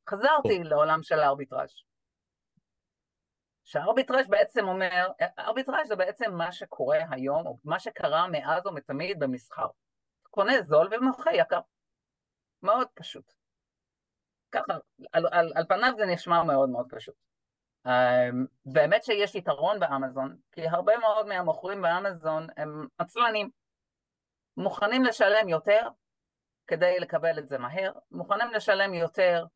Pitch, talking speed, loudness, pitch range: 180 Hz, 115 wpm, -27 LUFS, 150-215 Hz